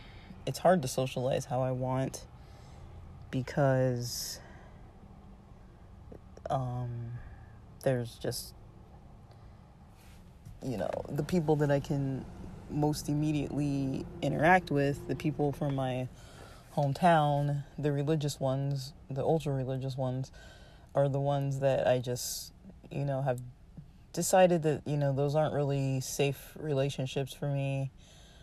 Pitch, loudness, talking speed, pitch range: 135 Hz, -32 LUFS, 115 wpm, 125-145 Hz